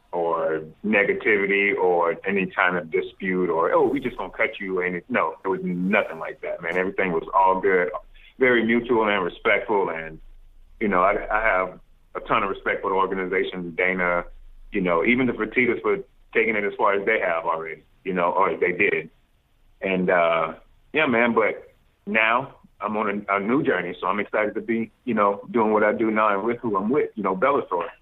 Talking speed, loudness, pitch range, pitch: 205 wpm, -23 LUFS, 95-125 Hz, 105 Hz